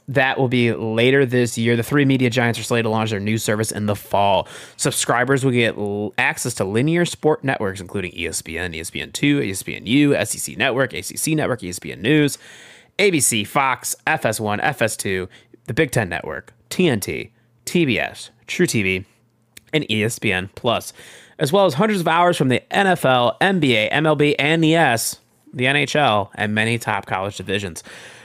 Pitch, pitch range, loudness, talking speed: 115 Hz, 105-145 Hz, -19 LUFS, 170 wpm